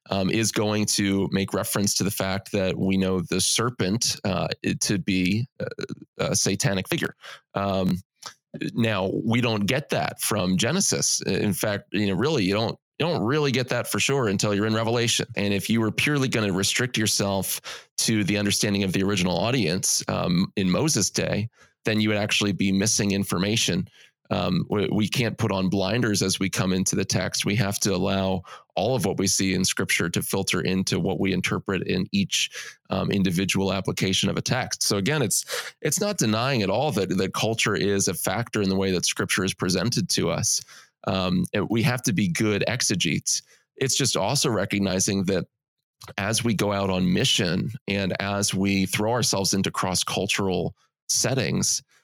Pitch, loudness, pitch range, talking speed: 100 Hz, -24 LUFS, 95-115 Hz, 185 wpm